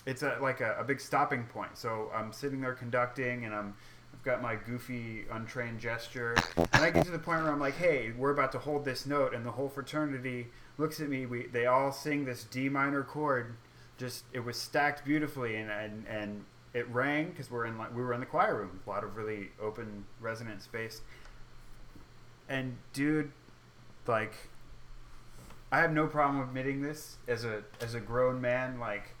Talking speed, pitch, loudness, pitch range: 195 wpm, 125 Hz, -34 LUFS, 115-140 Hz